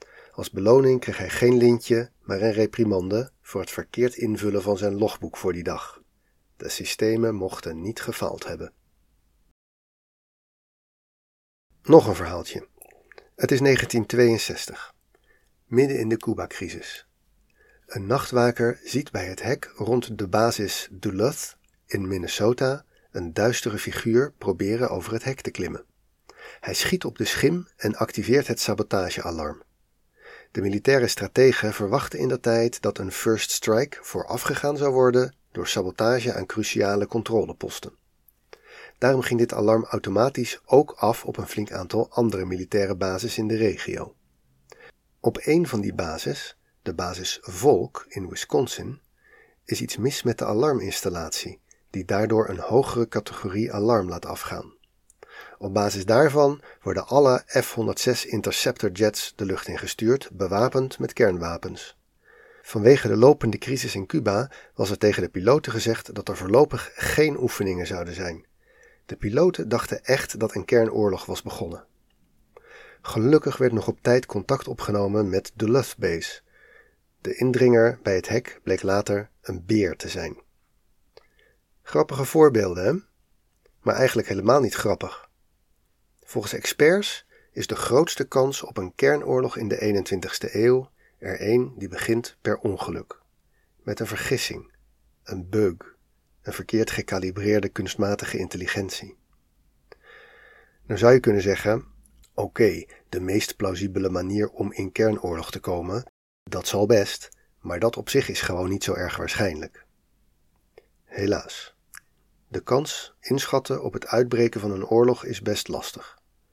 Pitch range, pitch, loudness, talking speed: 95-125 Hz, 110 Hz, -24 LUFS, 140 wpm